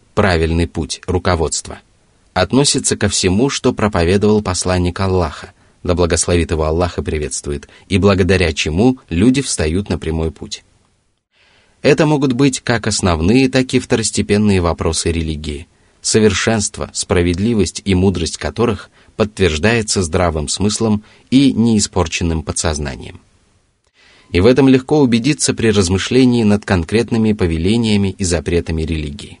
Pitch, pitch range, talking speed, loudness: 95 Hz, 85-110 Hz, 120 wpm, -15 LUFS